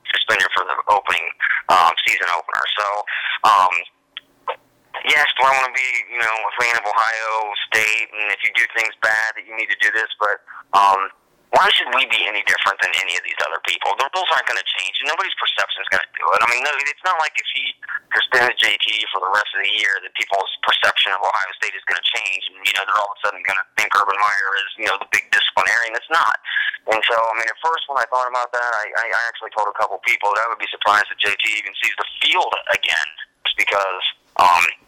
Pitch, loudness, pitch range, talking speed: 115 Hz, -18 LUFS, 110-125 Hz, 240 wpm